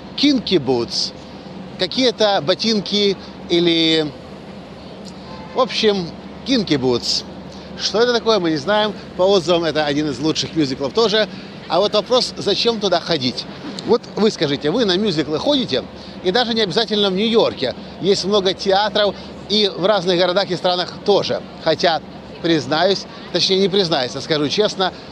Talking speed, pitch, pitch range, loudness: 145 wpm, 190 Hz, 165-210 Hz, -18 LUFS